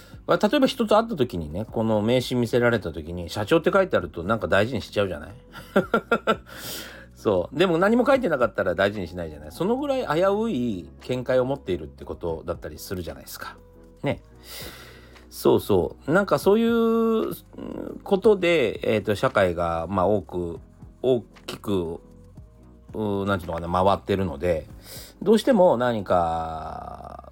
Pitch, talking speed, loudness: 110 Hz, 340 characters per minute, -24 LUFS